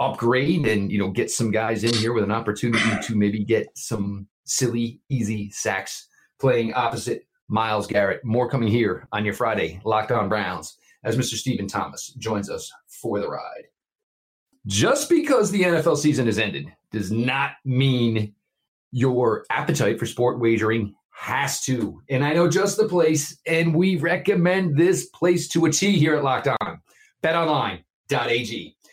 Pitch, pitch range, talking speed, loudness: 125 Hz, 110-165 Hz, 160 wpm, -22 LUFS